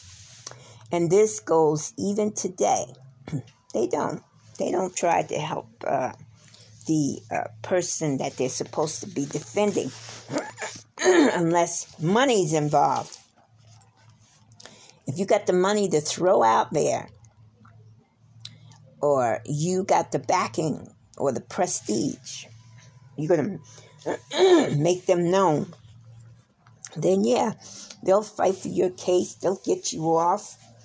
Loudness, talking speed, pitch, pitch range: -24 LUFS, 115 wpm, 145 Hz, 115-180 Hz